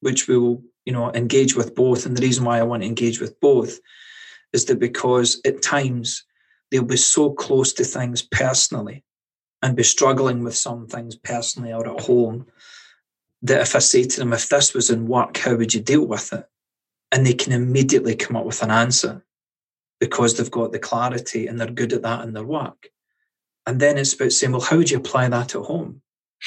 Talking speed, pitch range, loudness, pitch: 210 wpm, 120-135 Hz, -19 LUFS, 125 Hz